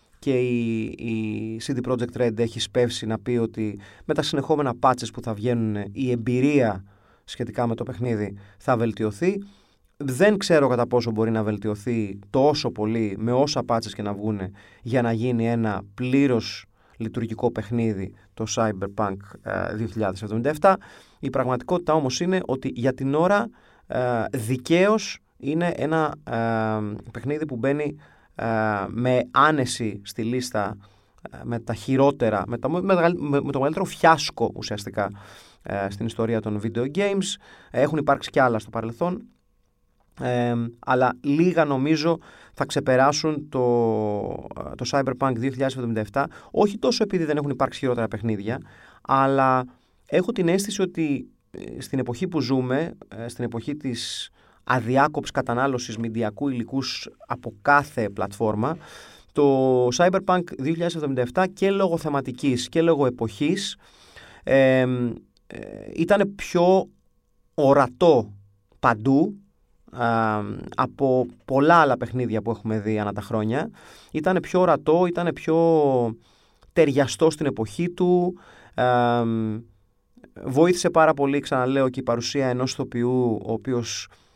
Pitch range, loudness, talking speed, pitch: 110-145 Hz, -23 LUFS, 130 wpm, 125 Hz